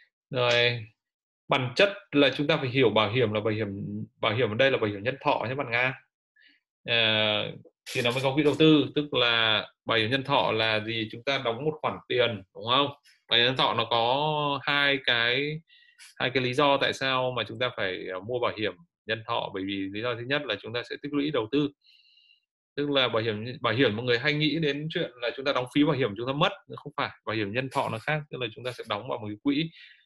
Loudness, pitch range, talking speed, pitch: -26 LUFS, 115-145 Hz, 250 wpm, 130 Hz